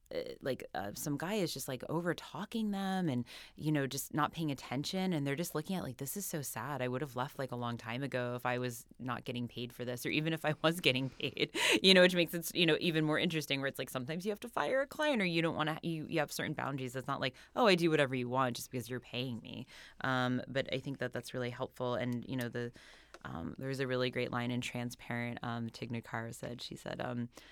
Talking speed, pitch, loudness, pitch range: 265 wpm, 135 Hz, -35 LUFS, 125-160 Hz